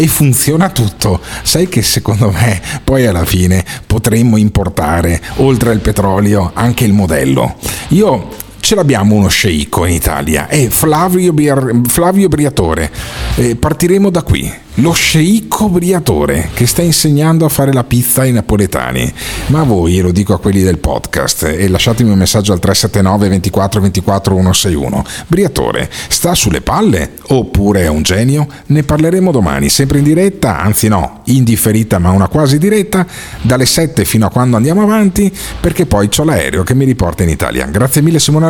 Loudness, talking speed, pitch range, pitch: -11 LUFS, 160 wpm, 95-150 Hz, 115 Hz